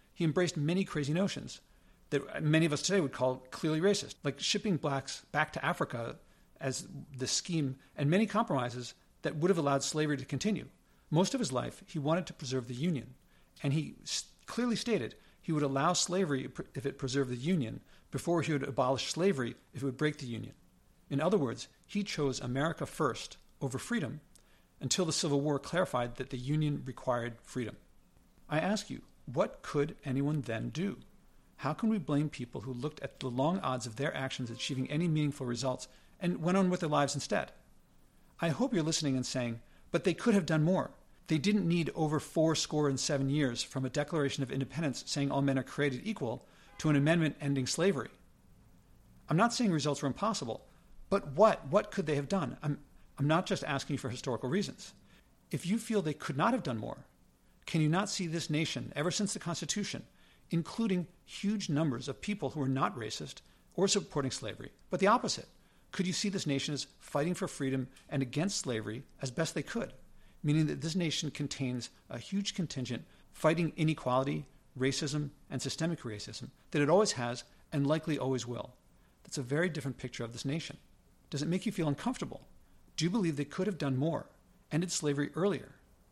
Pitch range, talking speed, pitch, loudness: 135-175 Hz, 190 wpm, 150 Hz, -34 LUFS